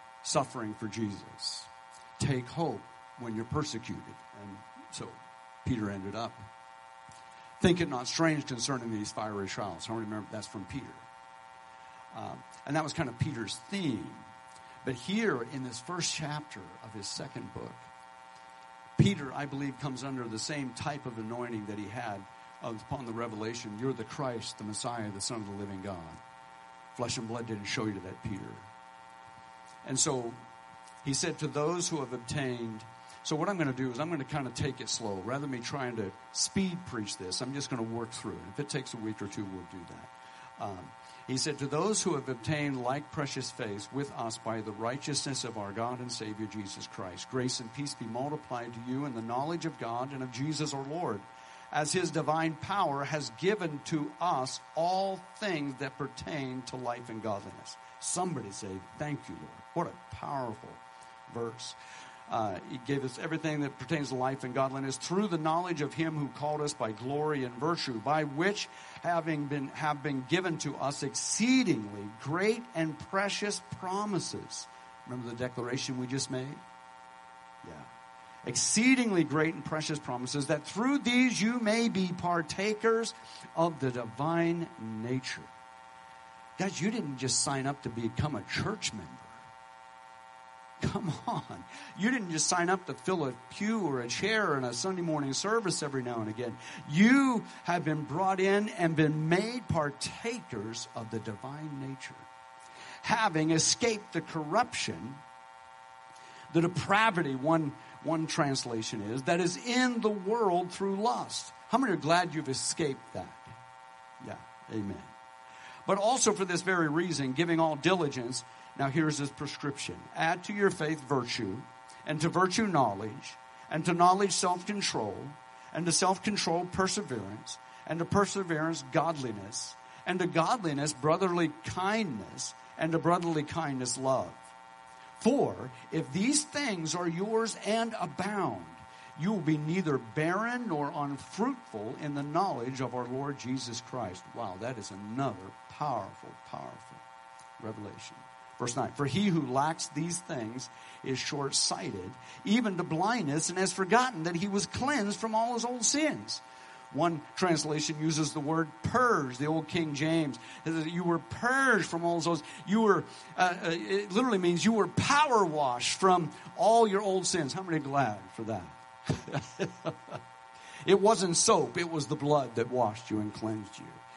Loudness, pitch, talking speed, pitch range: -32 LUFS, 135 Hz, 165 wpm, 100-165 Hz